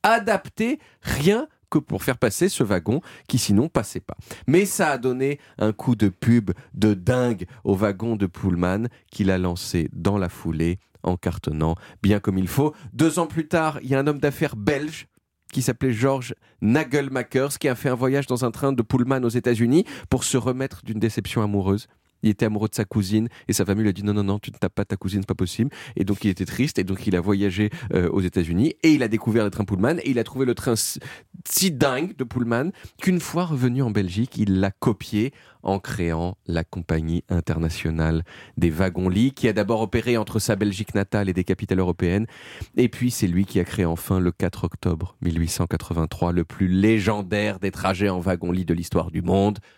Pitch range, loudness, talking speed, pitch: 95-130 Hz, -23 LUFS, 210 wpm, 105 Hz